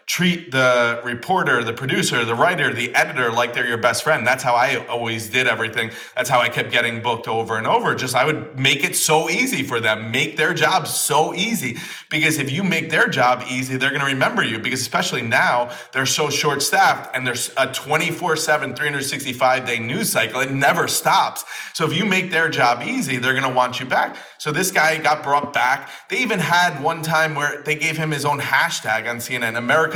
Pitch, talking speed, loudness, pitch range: 135 Hz, 215 wpm, -19 LUFS, 125-155 Hz